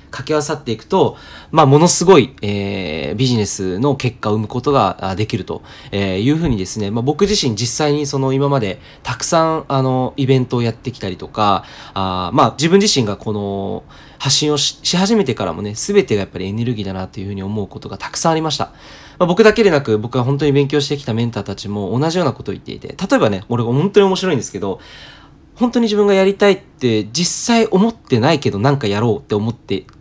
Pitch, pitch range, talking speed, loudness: 130 Hz, 105-155 Hz, 450 characters per minute, -16 LUFS